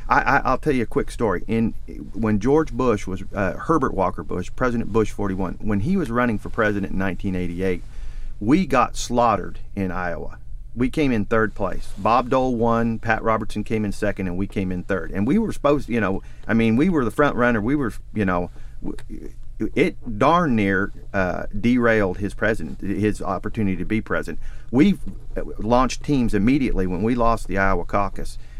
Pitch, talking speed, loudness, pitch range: 105 Hz, 190 wpm, -22 LUFS, 95-115 Hz